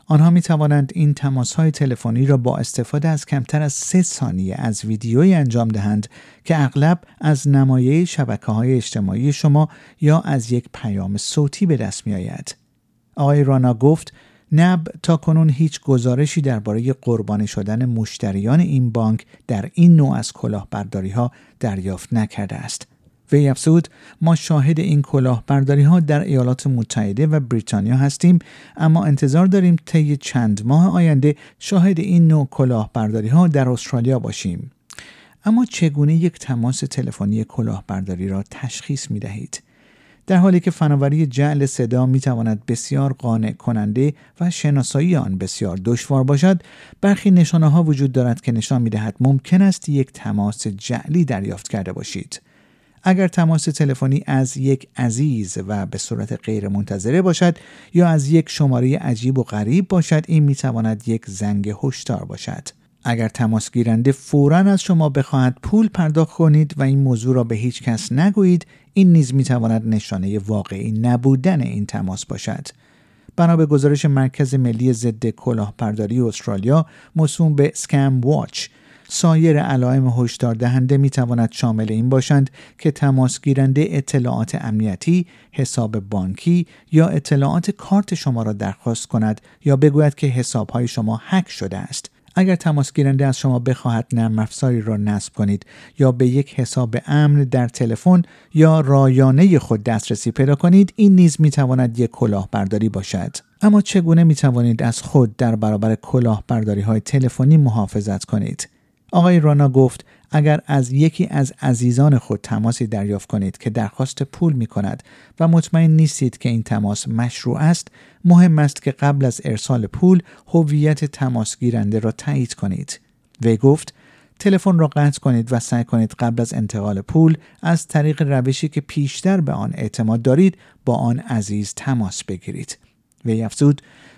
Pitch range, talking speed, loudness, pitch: 115-155 Hz, 150 wpm, -17 LUFS, 135 Hz